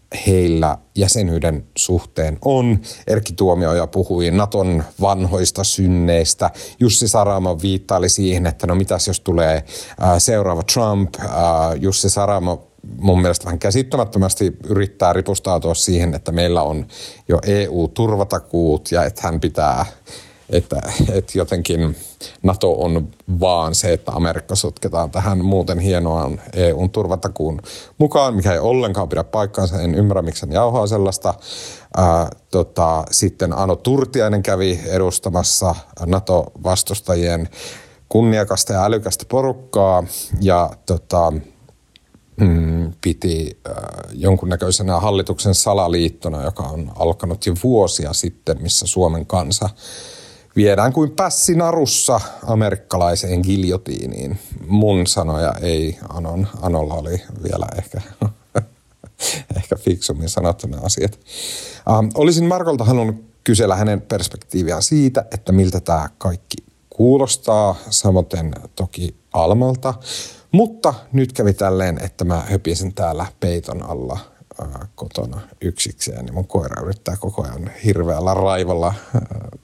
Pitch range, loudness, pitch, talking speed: 85-105 Hz, -18 LUFS, 95 Hz, 110 wpm